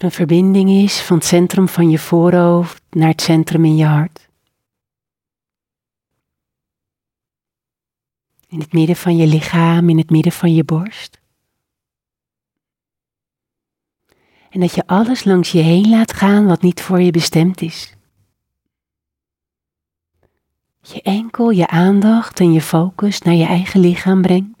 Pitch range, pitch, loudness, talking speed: 160-185 Hz, 170 Hz, -13 LUFS, 130 wpm